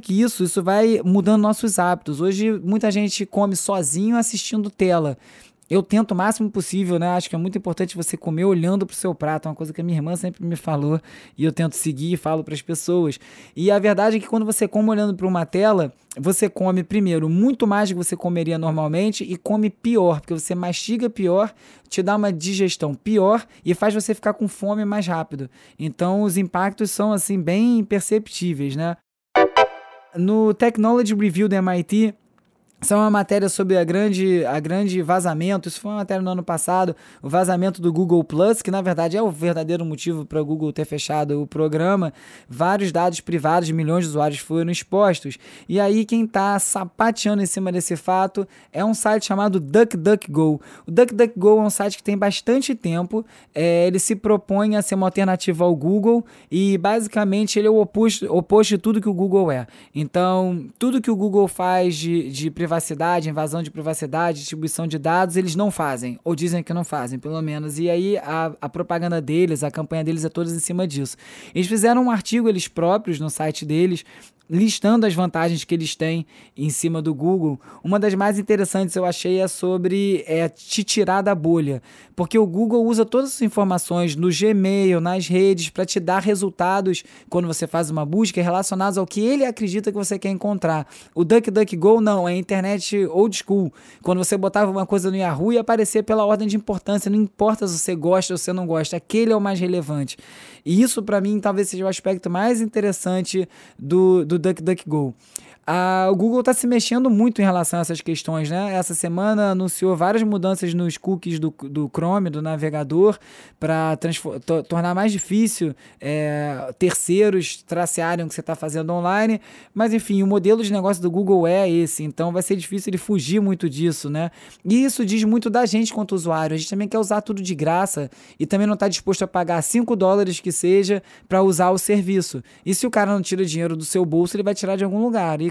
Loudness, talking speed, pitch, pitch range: -20 LUFS, 200 wpm, 185 Hz, 170-205 Hz